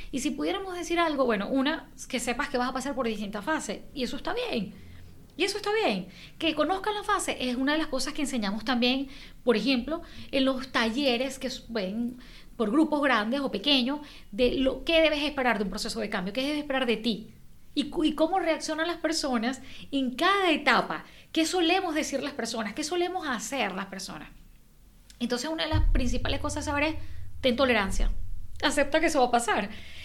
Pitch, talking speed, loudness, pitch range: 270 Hz, 200 wpm, -28 LUFS, 245-315 Hz